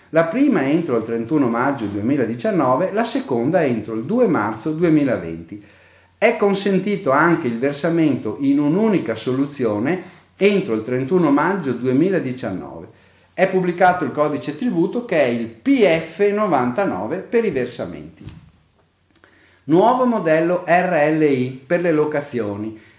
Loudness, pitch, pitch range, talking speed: -19 LUFS, 150 Hz, 115-185 Hz, 115 wpm